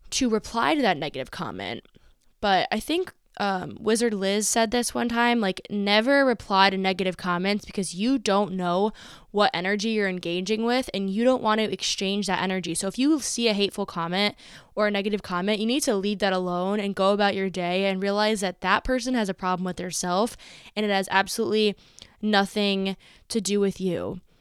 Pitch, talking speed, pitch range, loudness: 200 Hz, 195 wpm, 190-220 Hz, -25 LUFS